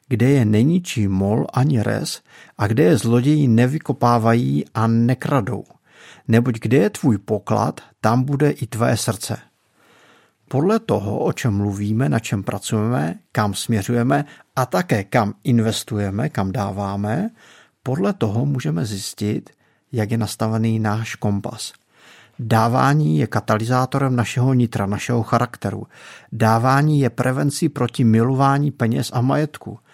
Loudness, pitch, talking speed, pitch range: -19 LUFS, 120 Hz, 125 wpm, 110-135 Hz